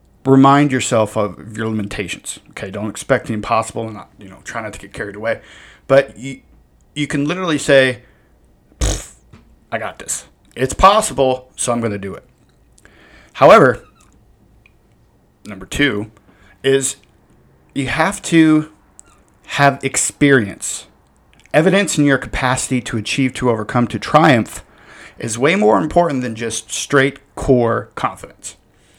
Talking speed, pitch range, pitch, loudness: 135 wpm, 105-140 Hz, 125 Hz, -16 LUFS